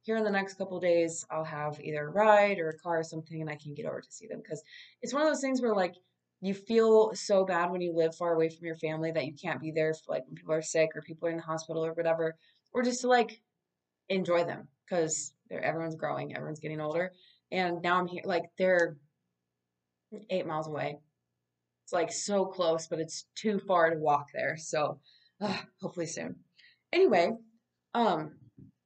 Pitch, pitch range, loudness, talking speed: 170 Hz, 155-195 Hz, -31 LUFS, 210 wpm